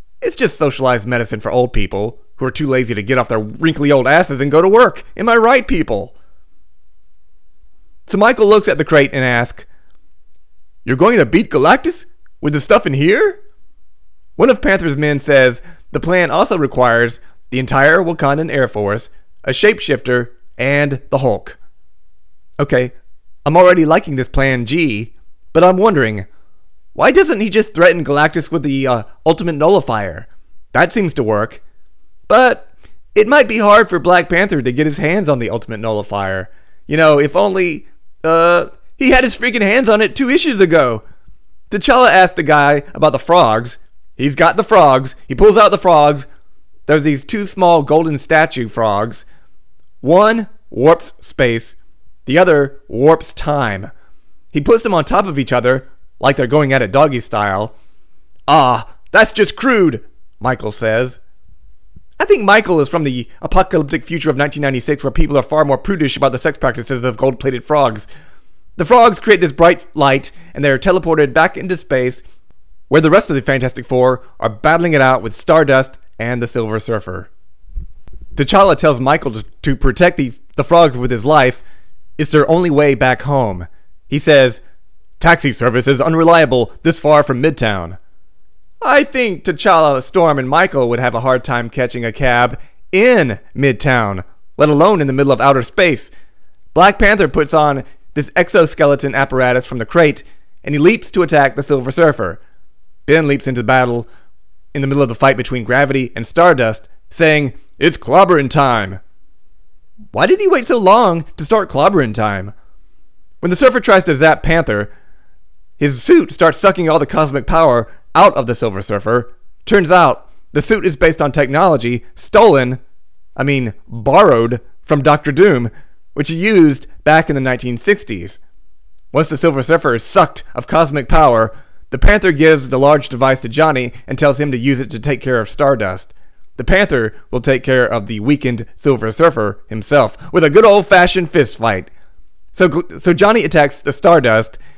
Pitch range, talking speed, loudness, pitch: 120-165 Hz, 170 wpm, -13 LUFS, 140 Hz